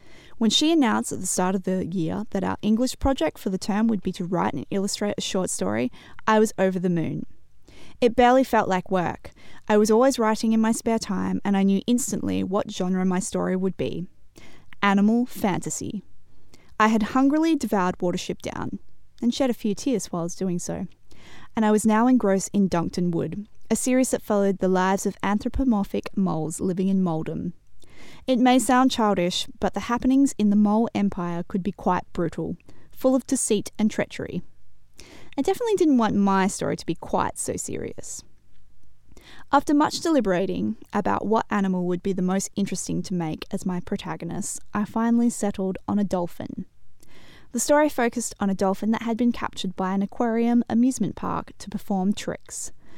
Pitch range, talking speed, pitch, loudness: 185-230 Hz, 185 wpm, 205 Hz, -24 LUFS